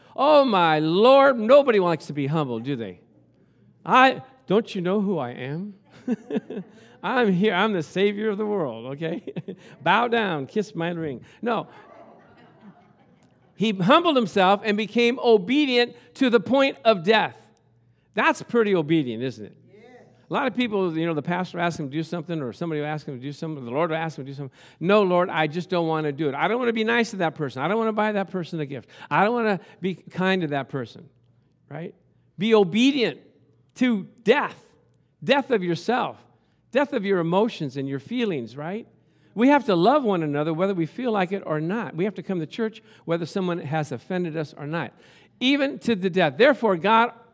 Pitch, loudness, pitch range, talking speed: 185 Hz, -23 LUFS, 155-225 Hz, 205 wpm